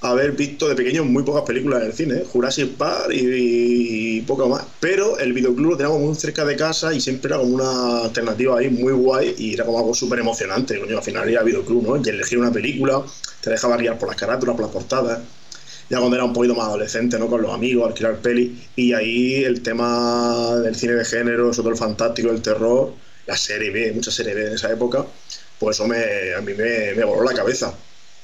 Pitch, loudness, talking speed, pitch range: 120 Hz, -20 LUFS, 225 wpm, 115-130 Hz